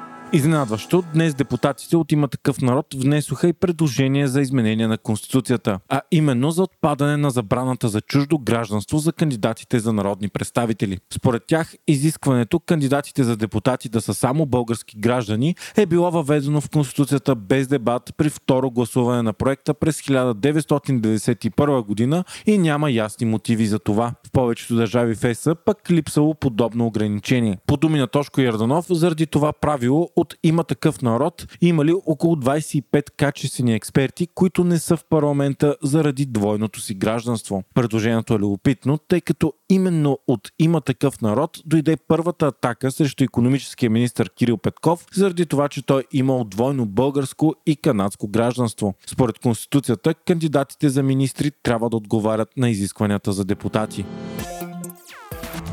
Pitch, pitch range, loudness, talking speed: 135 Hz, 115-155 Hz, -20 LUFS, 145 wpm